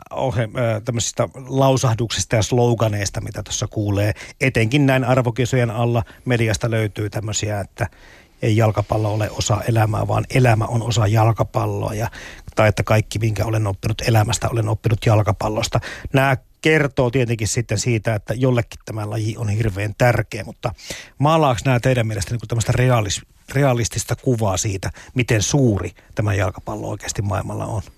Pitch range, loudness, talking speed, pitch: 105-120 Hz, -20 LUFS, 140 wpm, 115 Hz